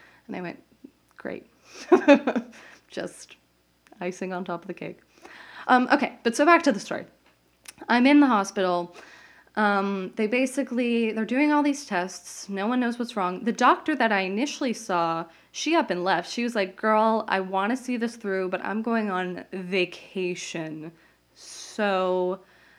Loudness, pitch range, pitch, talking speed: -24 LUFS, 185-250 Hz, 215 Hz, 165 wpm